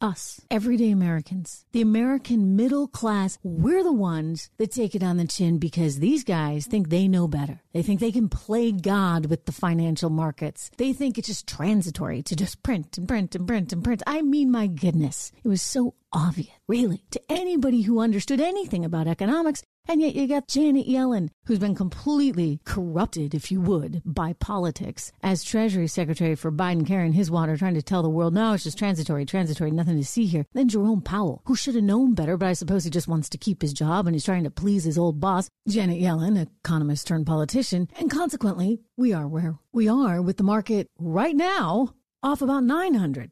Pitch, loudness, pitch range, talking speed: 190 Hz, -24 LUFS, 165-230 Hz, 200 wpm